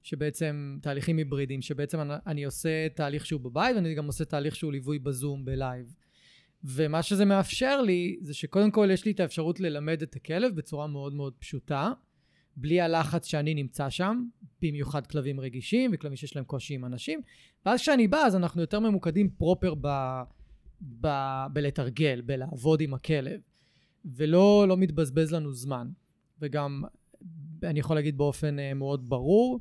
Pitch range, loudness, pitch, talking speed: 140-175 Hz, -29 LUFS, 155 Hz, 155 wpm